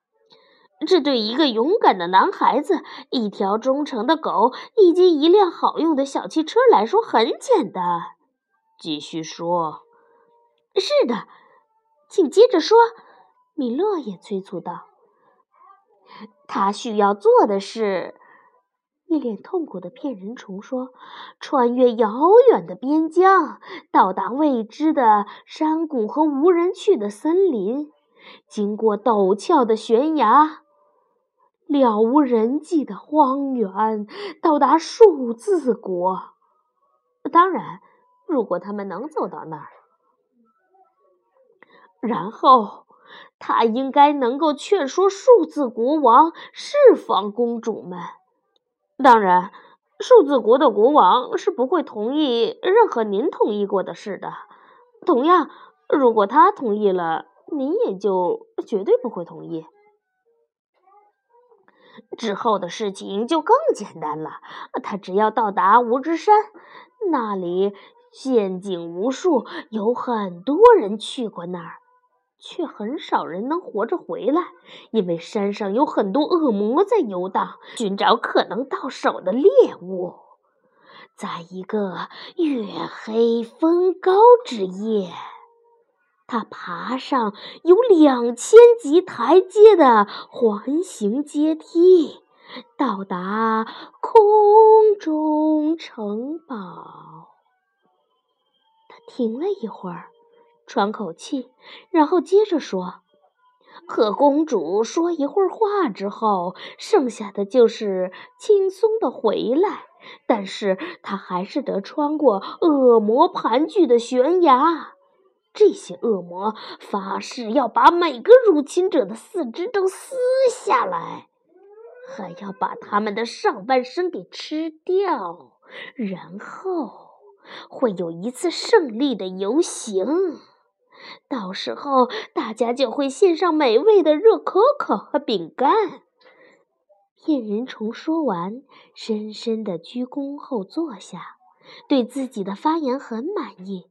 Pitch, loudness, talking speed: 315 Hz, -19 LUFS, 165 characters per minute